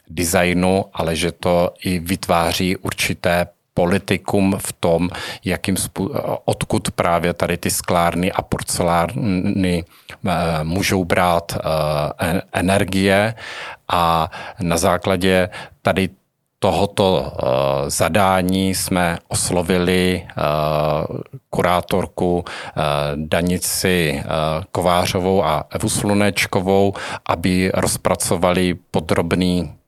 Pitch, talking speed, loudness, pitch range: 90 Hz, 75 wpm, -19 LUFS, 85-95 Hz